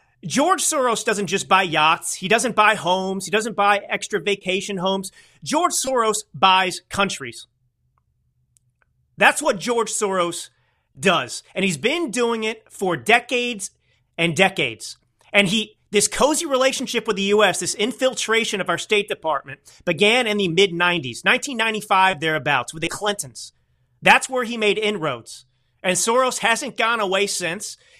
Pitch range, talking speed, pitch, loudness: 175-225 Hz, 145 wpm, 200 Hz, -20 LUFS